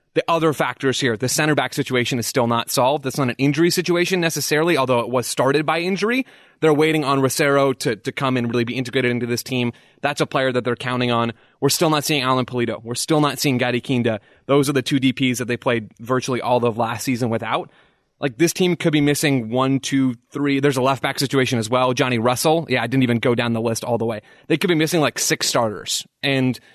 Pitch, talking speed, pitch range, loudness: 130 Hz, 240 wpm, 120-150 Hz, -20 LUFS